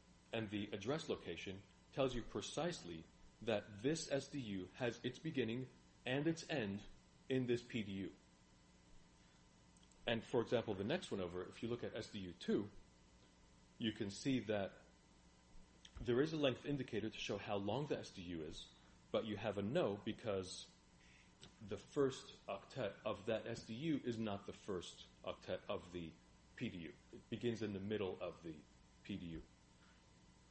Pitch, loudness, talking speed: 100 Hz, -44 LUFS, 150 wpm